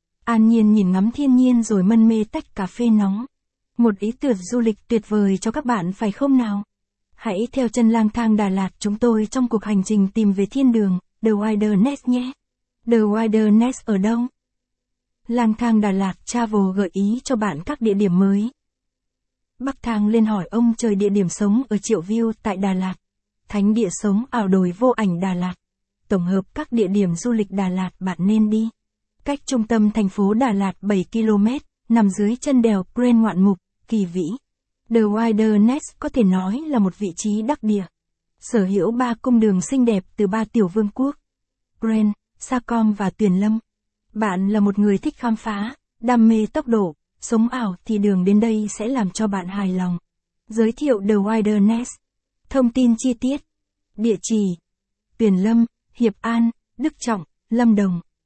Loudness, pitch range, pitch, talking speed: -20 LUFS, 200-235 Hz, 215 Hz, 195 wpm